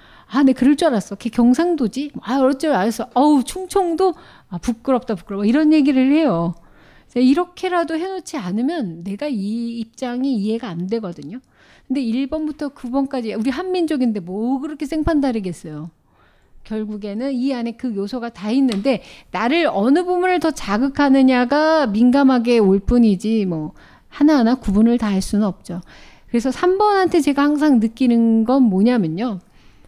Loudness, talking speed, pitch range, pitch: -18 LUFS, 325 characters per minute, 215-290 Hz, 250 Hz